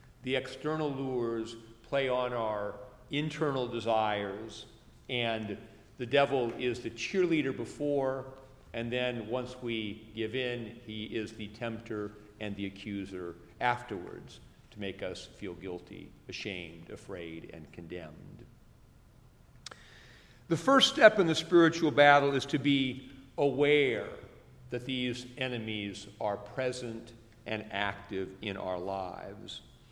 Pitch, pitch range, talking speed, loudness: 115 Hz, 105-130 Hz, 120 wpm, -31 LUFS